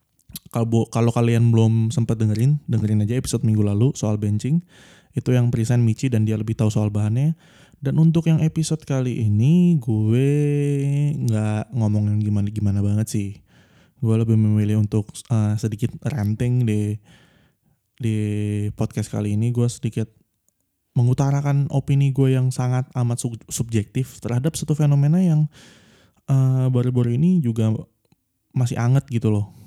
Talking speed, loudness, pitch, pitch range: 140 wpm, -21 LUFS, 120 Hz, 110-140 Hz